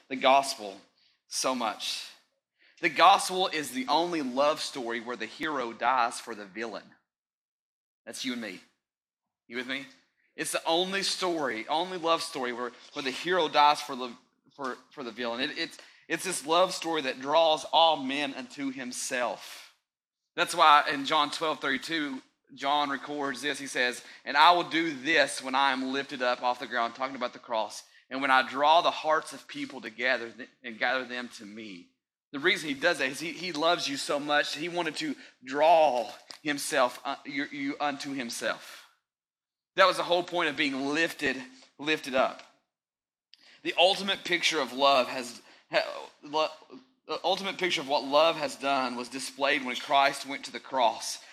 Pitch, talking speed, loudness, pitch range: 145 Hz, 180 wpm, -28 LUFS, 130-175 Hz